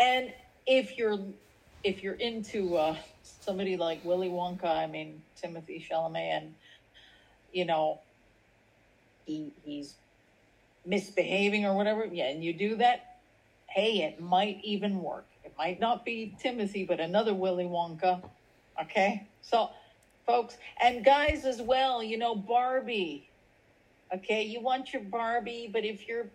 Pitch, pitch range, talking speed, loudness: 195 Hz, 160-230 Hz, 135 wpm, -31 LUFS